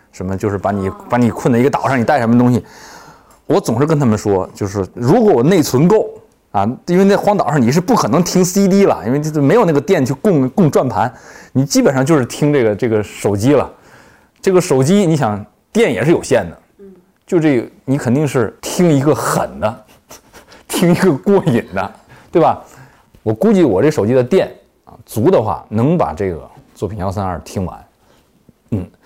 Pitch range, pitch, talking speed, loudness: 115-175 Hz, 135 Hz, 275 characters per minute, -14 LUFS